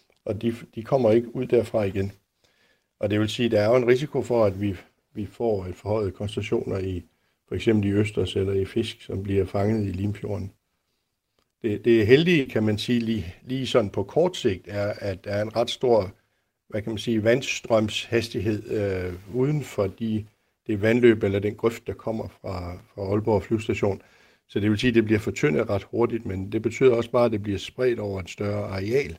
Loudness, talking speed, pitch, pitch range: -25 LUFS, 205 wpm, 105 Hz, 100-115 Hz